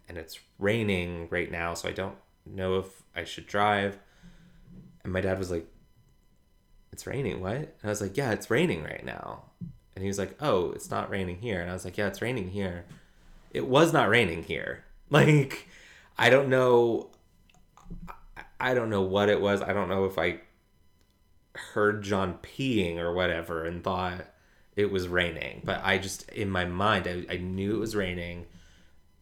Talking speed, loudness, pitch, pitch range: 185 wpm, -28 LUFS, 95 Hz, 90-105 Hz